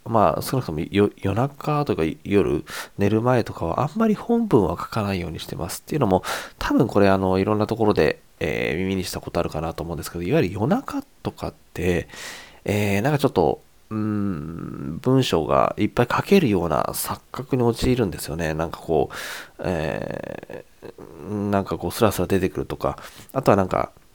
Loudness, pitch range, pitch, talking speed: -23 LUFS, 90-125 Hz, 100 Hz, 370 characters per minute